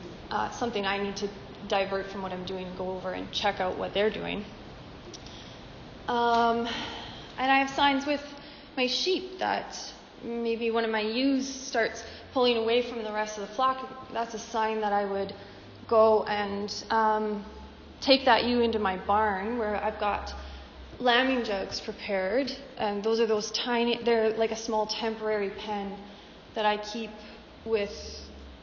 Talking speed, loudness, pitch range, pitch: 165 wpm, -28 LUFS, 205-240 Hz, 220 Hz